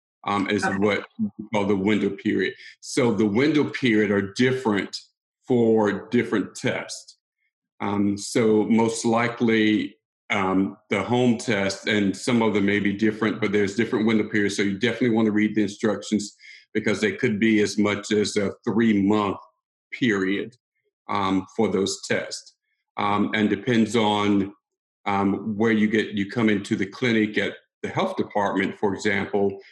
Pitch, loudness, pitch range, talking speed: 105 Hz, -23 LUFS, 100-115 Hz, 160 wpm